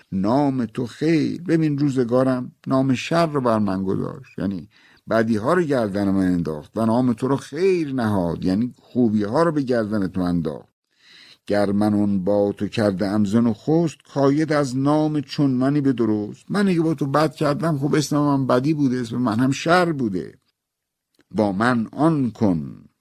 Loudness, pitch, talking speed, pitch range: -21 LUFS, 130 Hz, 175 wpm, 105-145 Hz